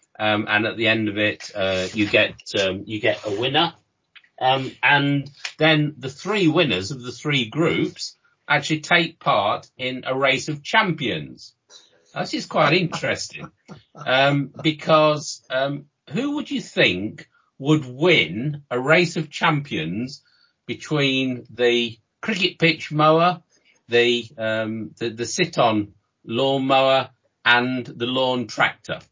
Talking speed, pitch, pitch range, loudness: 135 wpm, 135 Hz, 120-160 Hz, -21 LUFS